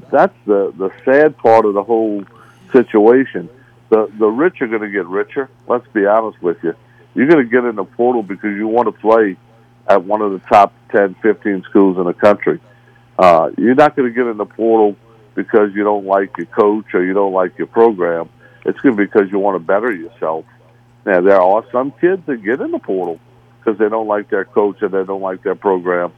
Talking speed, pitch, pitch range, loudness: 225 wpm, 110 Hz, 100-120 Hz, -15 LUFS